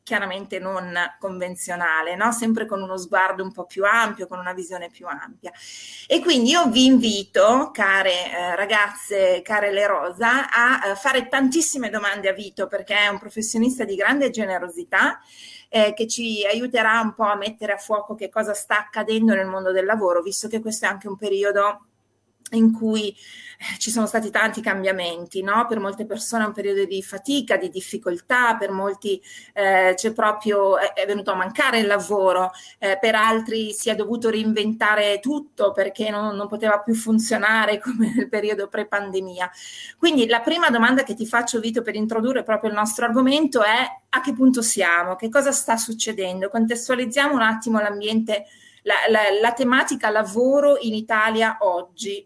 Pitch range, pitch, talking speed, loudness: 195-230 Hz, 215 Hz, 170 wpm, -20 LUFS